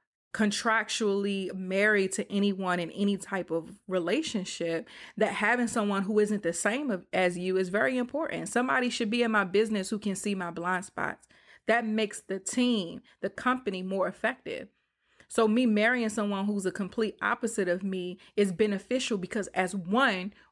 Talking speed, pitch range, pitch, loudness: 165 wpm, 190-225 Hz, 205 Hz, -29 LUFS